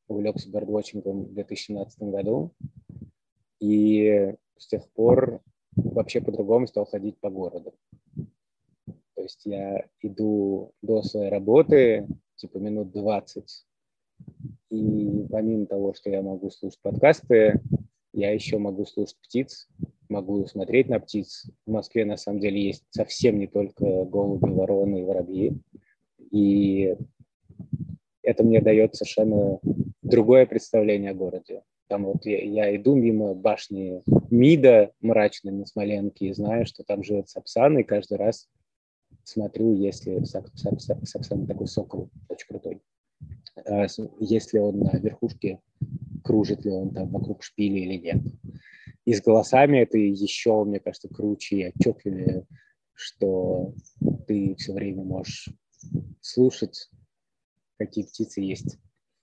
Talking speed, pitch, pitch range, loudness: 125 wpm, 105 Hz, 100-110 Hz, -24 LUFS